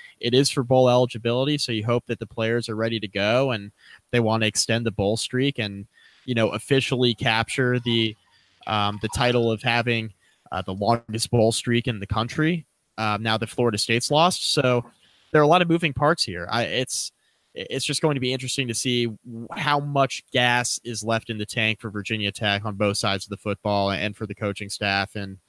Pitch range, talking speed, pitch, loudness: 105-125 Hz, 210 wpm, 115 Hz, -23 LUFS